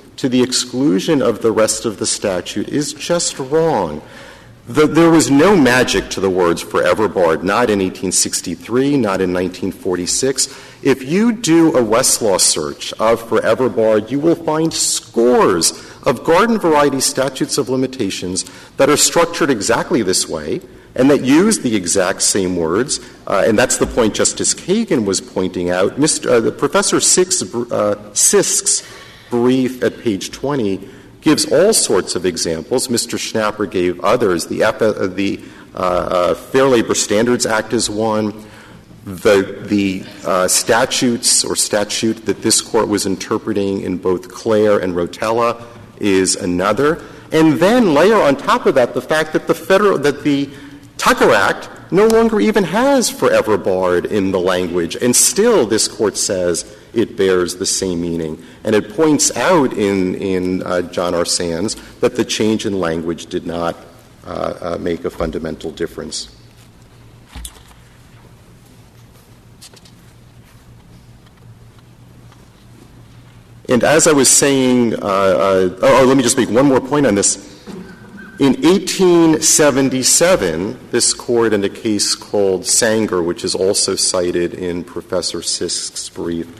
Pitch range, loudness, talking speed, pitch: 95-140 Hz, -15 LUFS, 145 wpm, 110 Hz